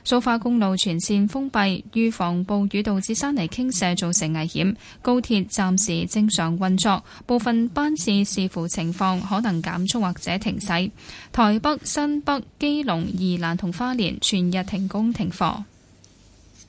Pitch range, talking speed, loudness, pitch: 180-230 Hz, 225 characters per minute, -22 LUFS, 200 Hz